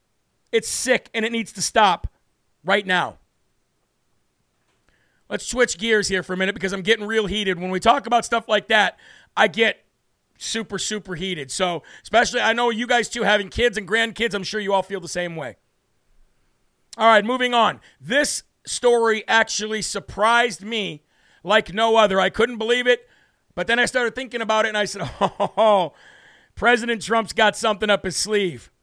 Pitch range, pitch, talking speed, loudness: 195-235 Hz, 220 Hz, 180 wpm, -20 LUFS